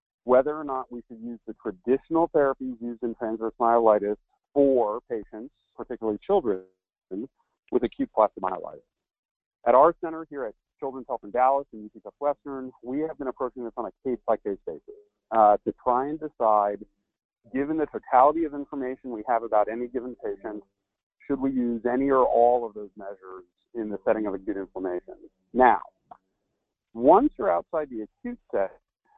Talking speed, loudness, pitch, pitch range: 170 wpm, -26 LUFS, 125 Hz, 110-140 Hz